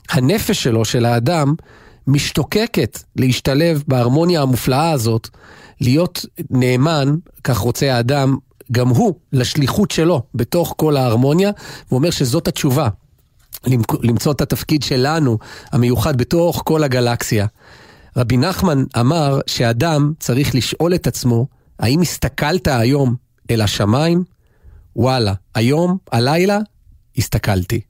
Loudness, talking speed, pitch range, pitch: -17 LUFS, 105 wpm, 120-155 Hz, 130 Hz